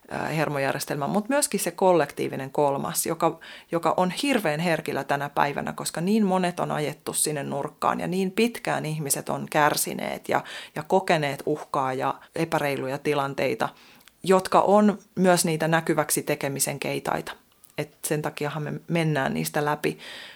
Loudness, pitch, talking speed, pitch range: -25 LUFS, 160 Hz, 140 wpm, 145-185 Hz